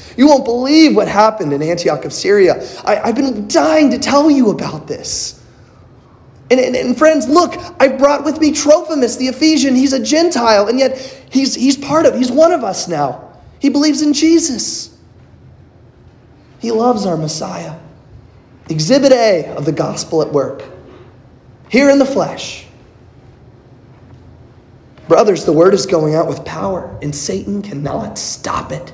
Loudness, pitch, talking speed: -13 LUFS, 235 Hz, 160 wpm